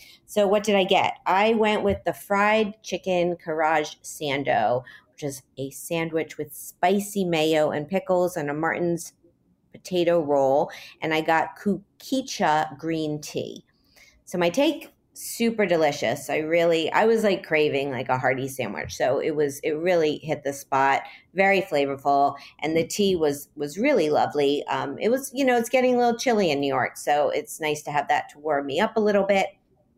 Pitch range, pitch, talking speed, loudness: 145-200 Hz, 165 Hz, 180 wpm, -24 LUFS